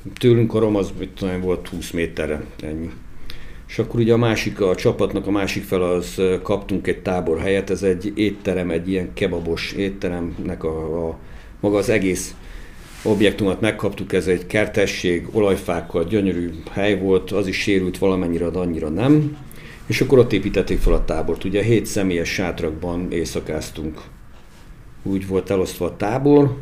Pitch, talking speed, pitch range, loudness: 95 Hz, 155 wpm, 85-100 Hz, -21 LUFS